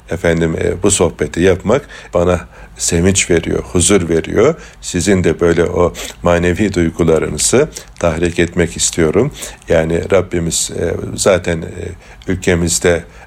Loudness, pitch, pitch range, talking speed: -14 LUFS, 85 Hz, 85-90 Hz, 115 wpm